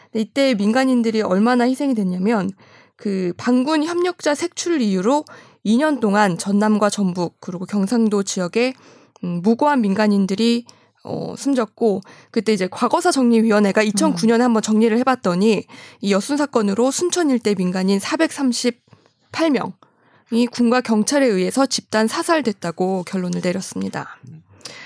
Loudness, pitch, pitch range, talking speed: -19 LUFS, 225 Hz, 200-255 Hz, 285 characters per minute